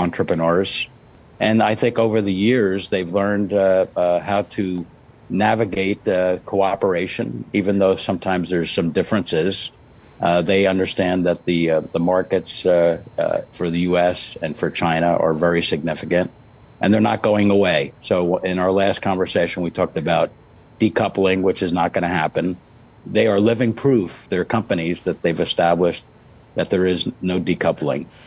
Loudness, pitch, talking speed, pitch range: -19 LUFS, 95 Hz, 160 wpm, 90-105 Hz